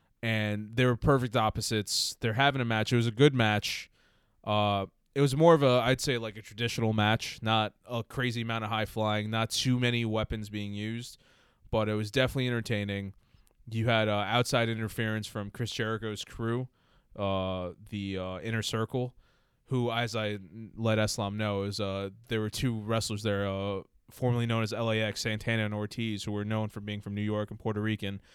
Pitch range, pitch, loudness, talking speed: 105-115 Hz, 110 Hz, -30 LUFS, 190 wpm